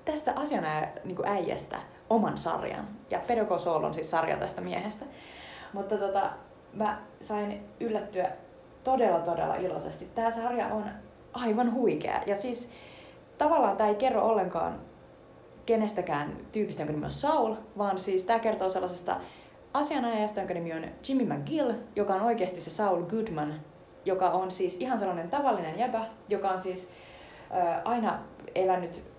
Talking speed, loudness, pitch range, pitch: 140 wpm, -30 LUFS, 185-230 Hz, 205 Hz